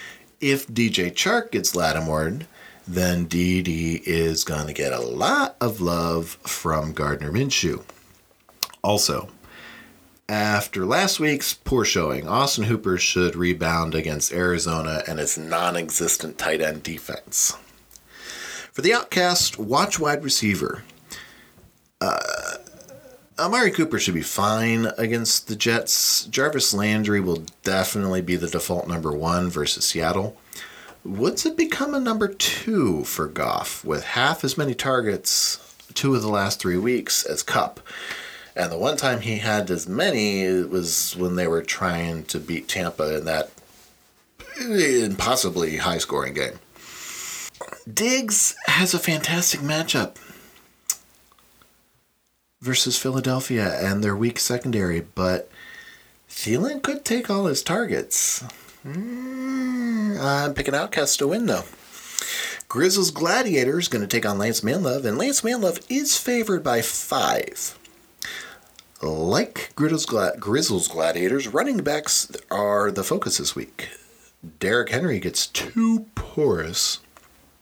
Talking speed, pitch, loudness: 125 wpm, 105 Hz, -22 LUFS